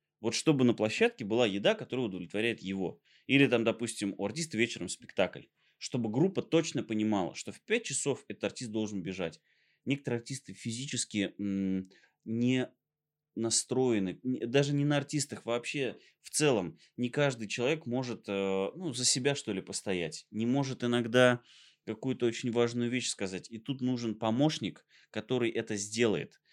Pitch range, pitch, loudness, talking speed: 105-130 Hz, 120 Hz, -32 LUFS, 150 wpm